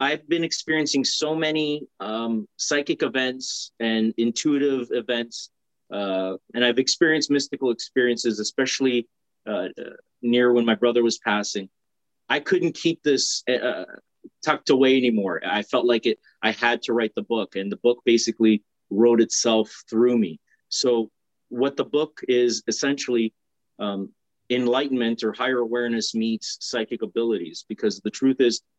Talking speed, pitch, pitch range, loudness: 145 wpm, 120 Hz, 115-135 Hz, -23 LUFS